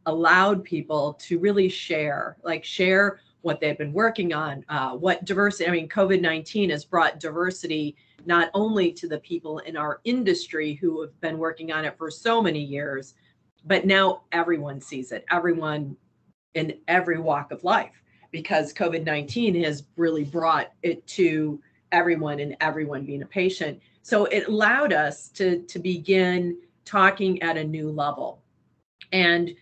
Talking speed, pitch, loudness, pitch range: 155 wpm, 165 Hz, -24 LUFS, 150-185 Hz